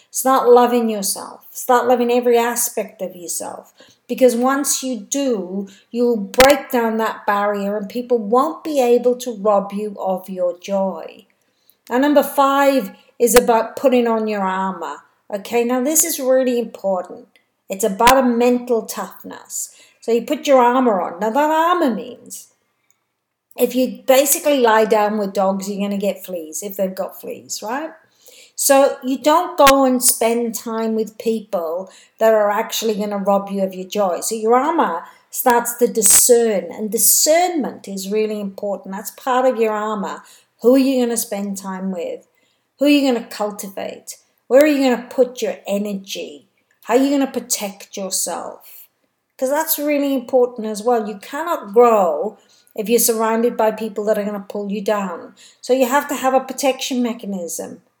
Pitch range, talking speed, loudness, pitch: 210-260 Hz, 175 wpm, -17 LUFS, 235 Hz